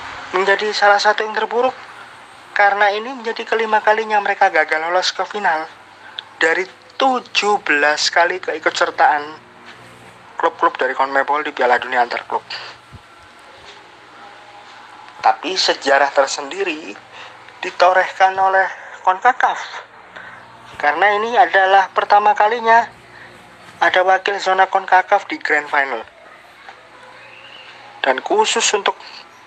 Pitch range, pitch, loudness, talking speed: 185-220 Hz, 200 Hz, -16 LUFS, 100 wpm